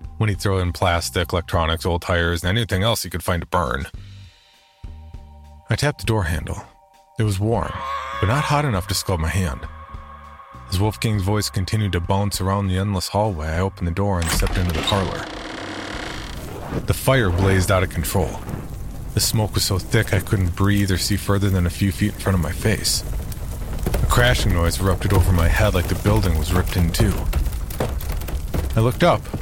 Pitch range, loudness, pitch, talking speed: 85-105 Hz, -21 LUFS, 95 Hz, 190 wpm